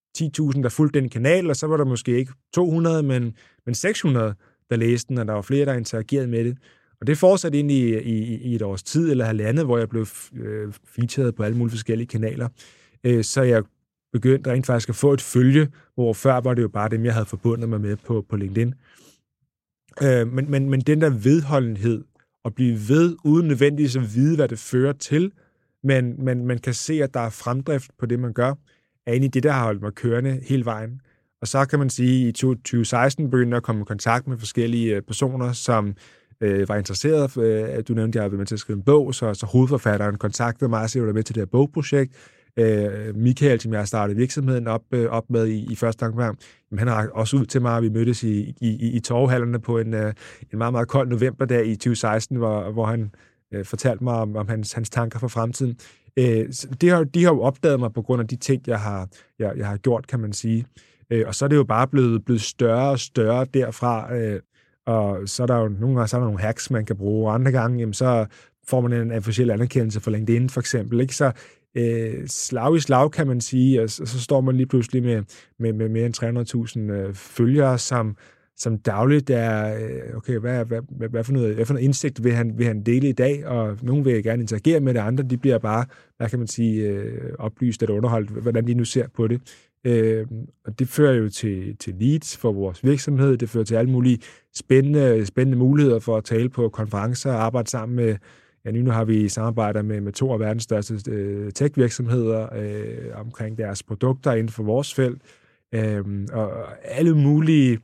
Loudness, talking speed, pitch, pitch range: -22 LUFS, 215 wpm, 120 Hz, 110-130 Hz